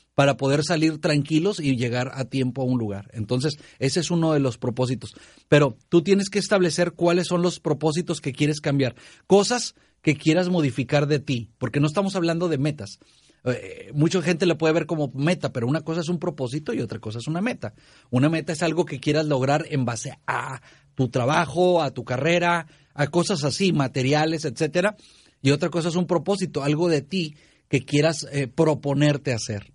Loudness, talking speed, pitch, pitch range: -23 LUFS, 195 wpm, 150 Hz, 135-175 Hz